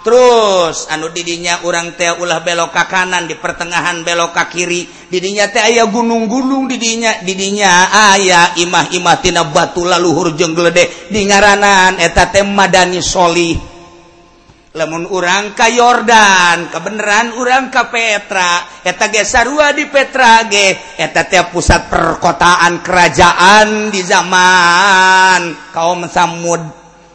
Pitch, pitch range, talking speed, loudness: 180 Hz, 170-205 Hz, 105 wpm, -10 LUFS